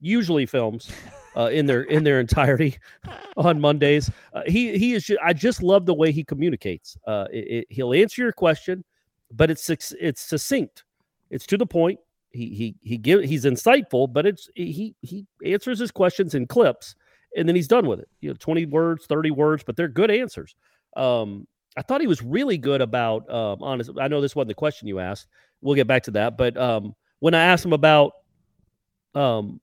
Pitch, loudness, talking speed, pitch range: 155 Hz, -22 LUFS, 200 wpm, 125-180 Hz